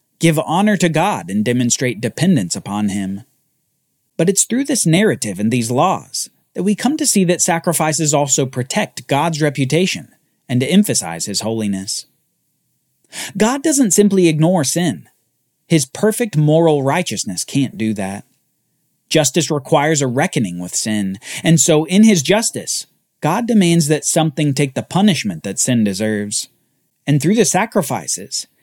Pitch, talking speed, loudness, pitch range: 155 Hz, 145 wpm, -16 LUFS, 125-185 Hz